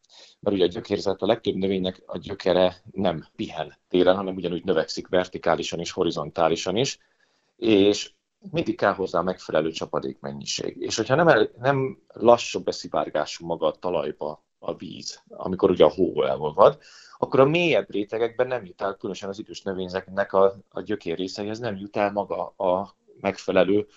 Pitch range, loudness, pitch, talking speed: 95-115 Hz, -24 LUFS, 100 Hz, 160 wpm